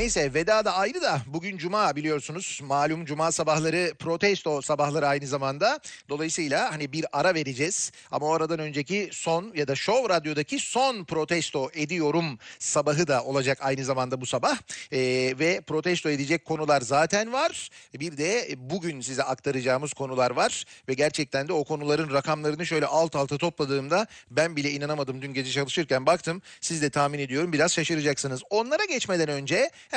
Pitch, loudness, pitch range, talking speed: 155 Hz, -26 LUFS, 140-170 Hz, 160 wpm